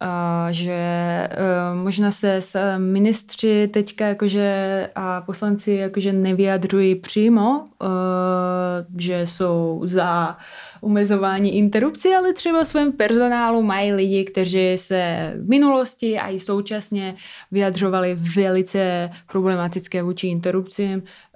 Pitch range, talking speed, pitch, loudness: 180-210 Hz, 110 wpm, 195 Hz, -20 LUFS